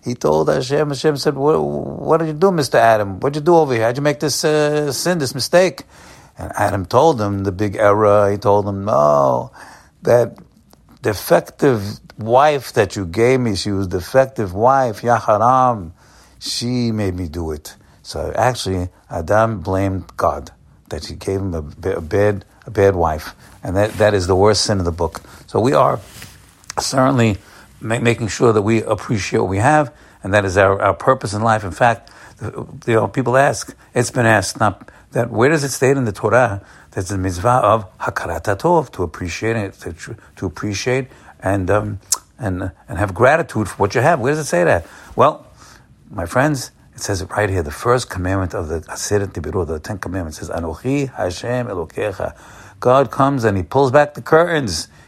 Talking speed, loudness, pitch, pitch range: 190 wpm, -17 LUFS, 105 Hz, 95-130 Hz